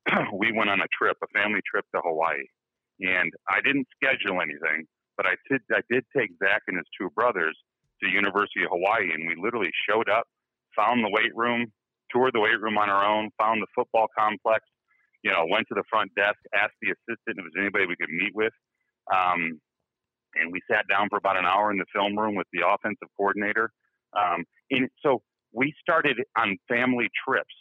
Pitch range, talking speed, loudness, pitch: 100-115 Hz, 200 wpm, -25 LUFS, 105 Hz